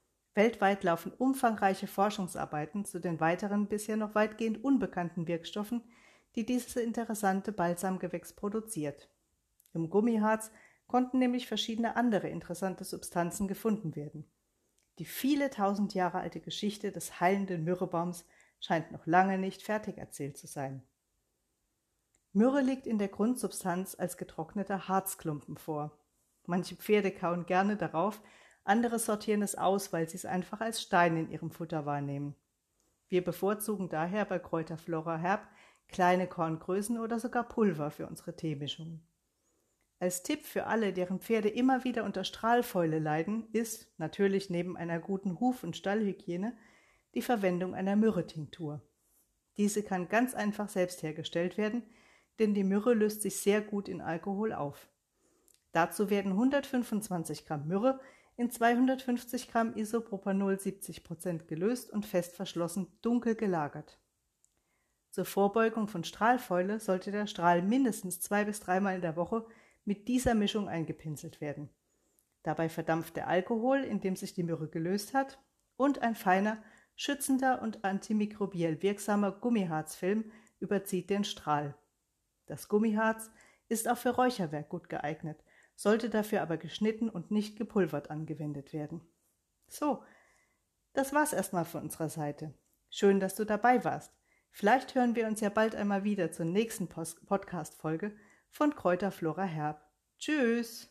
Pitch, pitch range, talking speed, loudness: 195 Hz, 170-220 Hz, 135 wpm, -33 LUFS